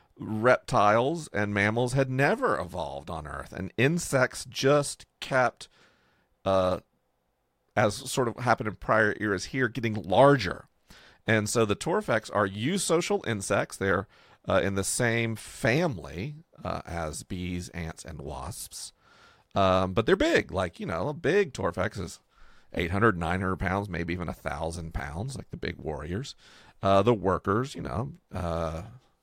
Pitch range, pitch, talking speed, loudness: 90-125 Hz, 105 Hz, 145 wpm, -28 LUFS